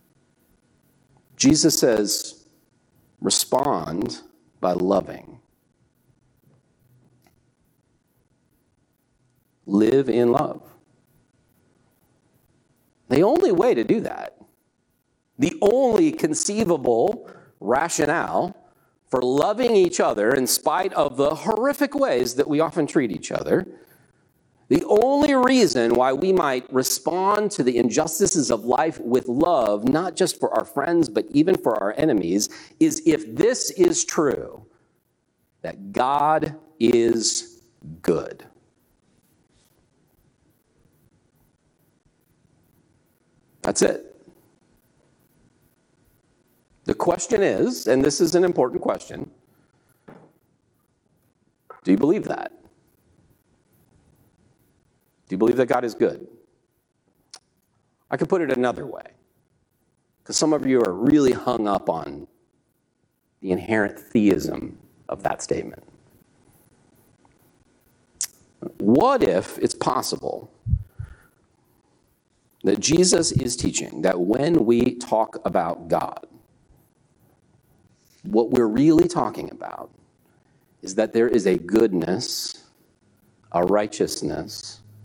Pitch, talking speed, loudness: 150 Hz, 95 wpm, -21 LUFS